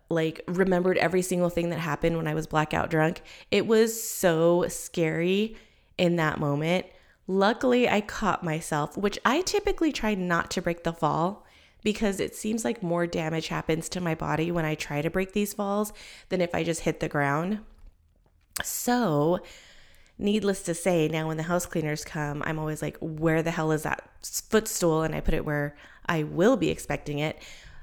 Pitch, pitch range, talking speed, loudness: 170 Hz, 155-200 Hz, 185 wpm, -27 LUFS